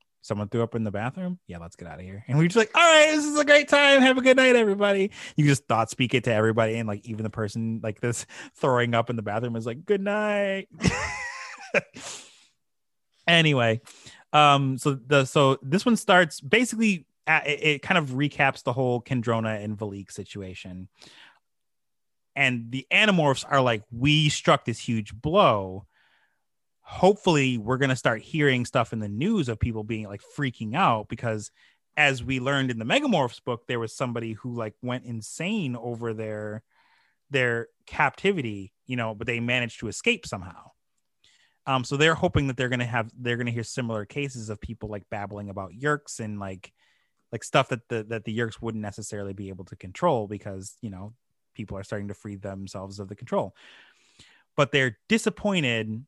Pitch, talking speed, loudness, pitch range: 120 Hz, 190 wpm, -24 LUFS, 110-150 Hz